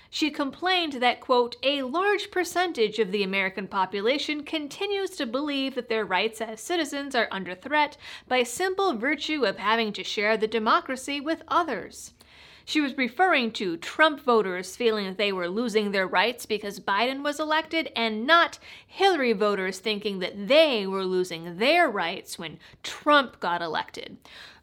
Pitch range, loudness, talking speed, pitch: 210-310 Hz, -25 LUFS, 160 wpm, 250 Hz